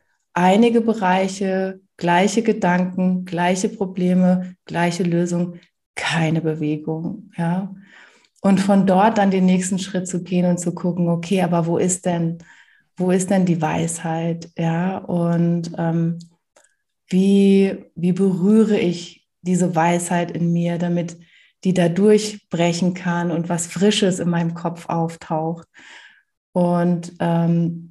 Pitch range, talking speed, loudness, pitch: 170-190 Hz, 125 wpm, -19 LUFS, 180 Hz